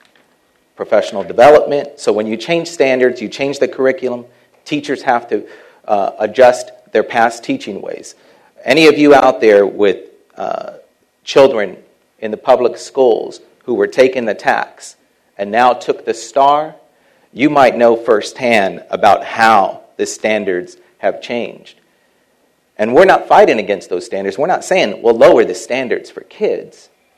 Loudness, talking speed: -13 LUFS, 150 wpm